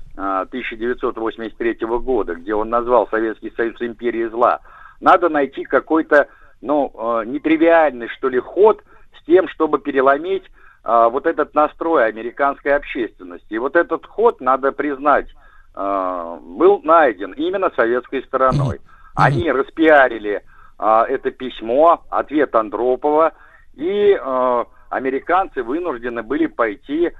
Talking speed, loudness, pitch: 105 wpm, -18 LUFS, 150 Hz